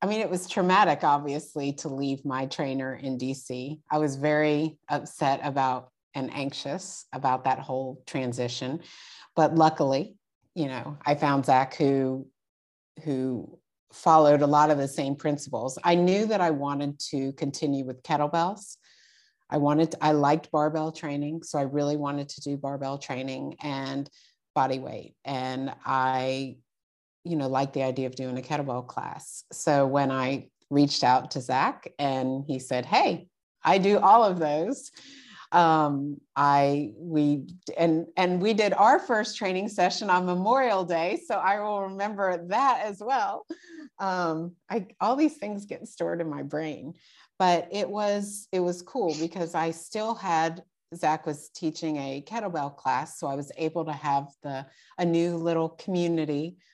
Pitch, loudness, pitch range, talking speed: 150 Hz, -27 LUFS, 140-175 Hz, 160 wpm